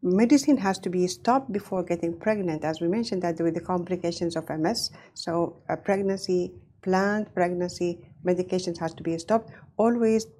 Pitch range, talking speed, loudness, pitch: 170-205 Hz, 160 wpm, -27 LUFS, 180 Hz